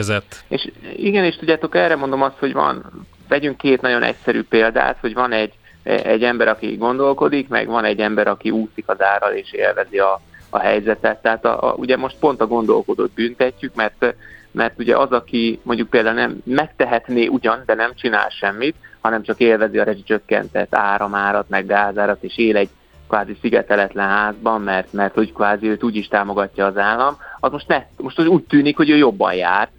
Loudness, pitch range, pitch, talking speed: -18 LUFS, 105-135 Hz, 115 Hz, 185 wpm